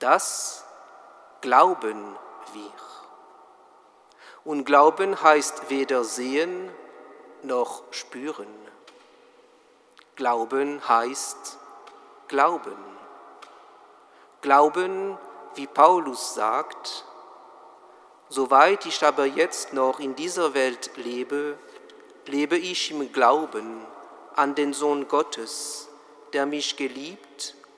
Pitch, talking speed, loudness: 150 Hz, 80 wpm, -23 LUFS